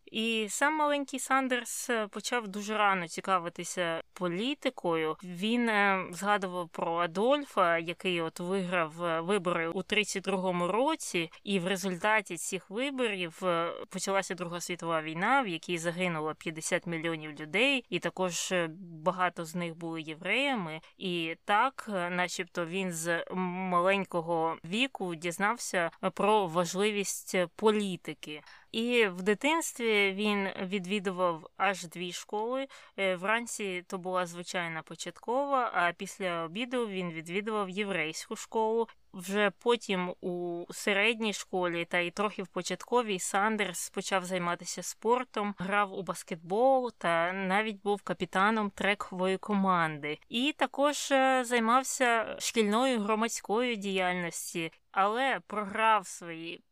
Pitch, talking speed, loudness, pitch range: 195 Hz, 110 wpm, -31 LUFS, 175-220 Hz